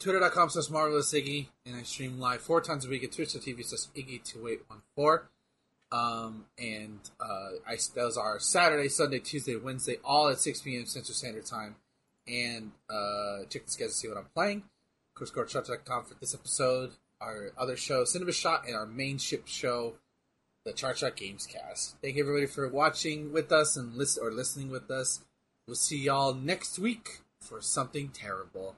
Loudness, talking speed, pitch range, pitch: -32 LUFS, 165 wpm, 120-150 Hz, 135 Hz